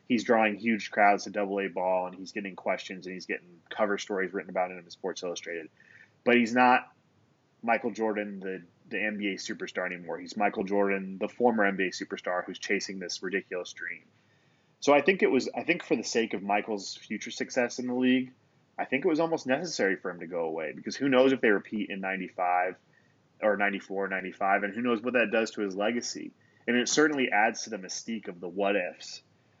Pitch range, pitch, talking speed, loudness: 95-125 Hz, 105 Hz, 215 wpm, -29 LUFS